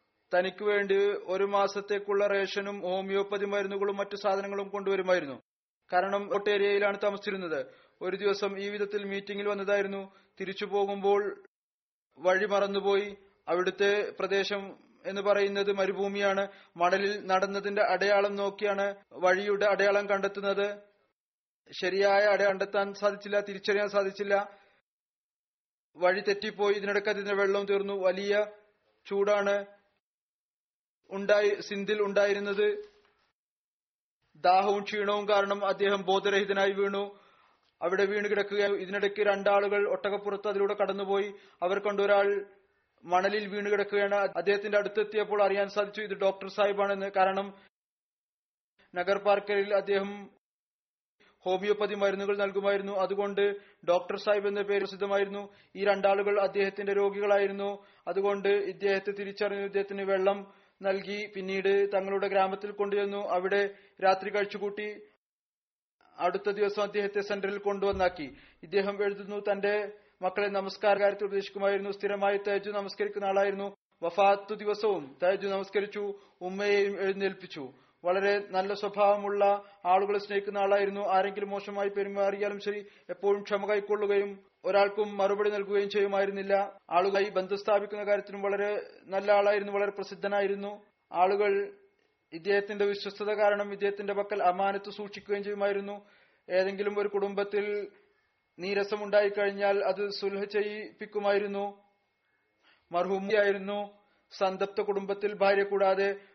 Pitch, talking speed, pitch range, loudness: 200 Hz, 95 wpm, 195-205 Hz, -29 LUFS